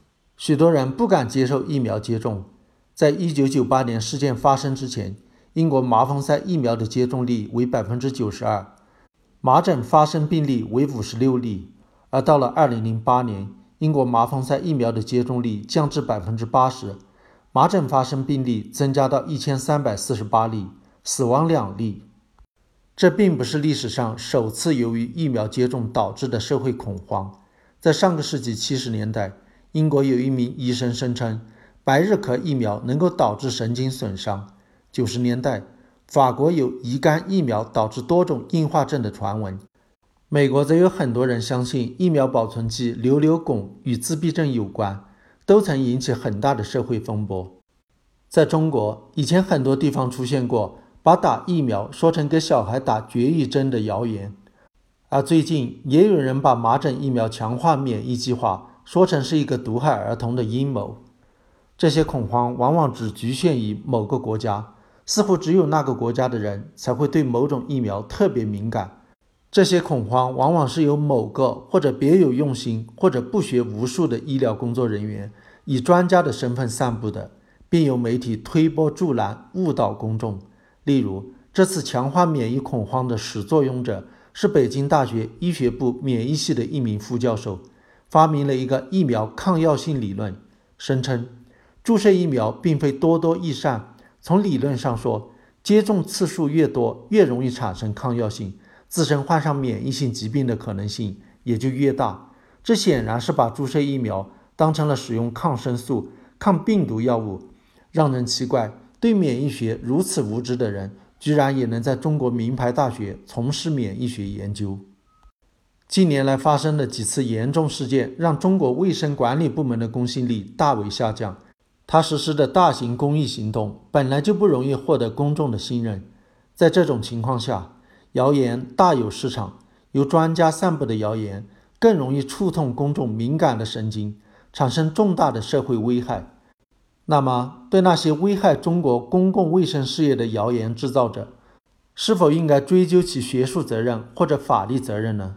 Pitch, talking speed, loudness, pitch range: 130 Hz, 260 characters per minute, -21 LUFS, 115-150 Hz